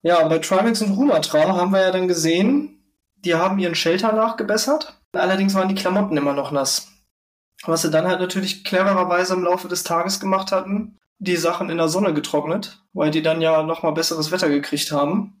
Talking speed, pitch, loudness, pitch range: 190 wpm, 180 Hz, -20 LUFS, 160-195 Hz